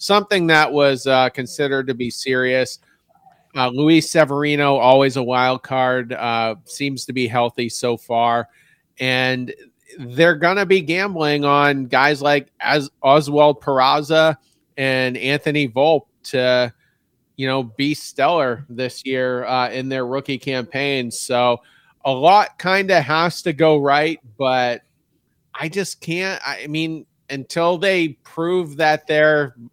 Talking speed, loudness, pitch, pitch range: 135 wpm, -18 LUFS, 140 Hz, 130-155 Hz